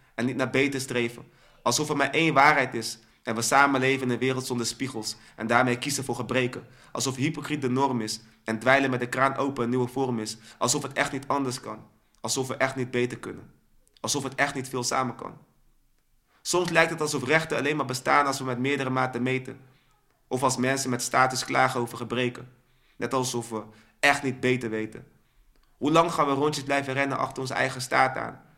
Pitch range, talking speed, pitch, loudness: 120-140 Hz, 210 wpm, 130 Hz, -26 LUFS